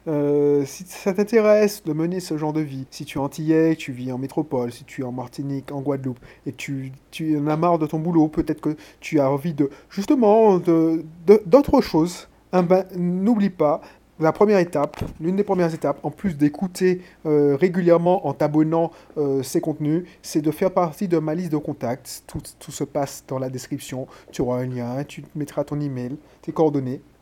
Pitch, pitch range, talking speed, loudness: 155 Hz, 140-175 Hz, 205 wpm, -22 LUFS